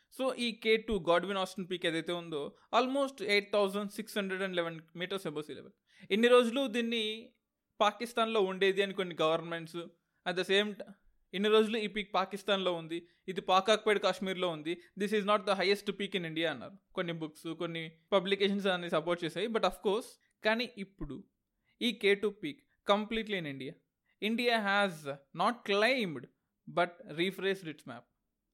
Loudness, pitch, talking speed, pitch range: -32 LUFS, 195 Hz, 165 wpm, 175-215 Hz